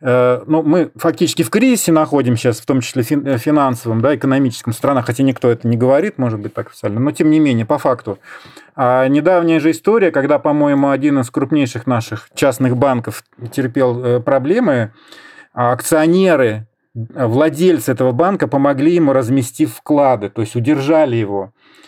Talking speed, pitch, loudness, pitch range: 155 wpm, 135 Hz, -15 LUFS, 120-150 Hz